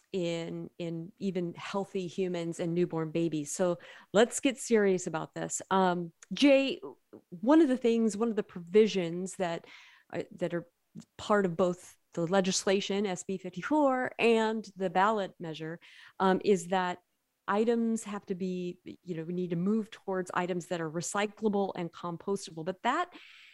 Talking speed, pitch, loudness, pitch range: 155 wpm, 190 Hz, -31 LUFS, 175-210 Hz